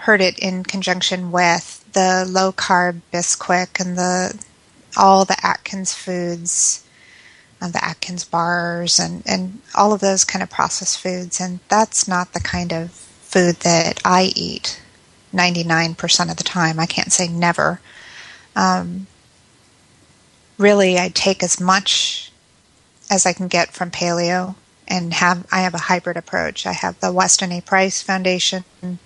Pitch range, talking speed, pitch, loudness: 175-190 Hz, 155 wpm, 180 Hz, -17 LUFS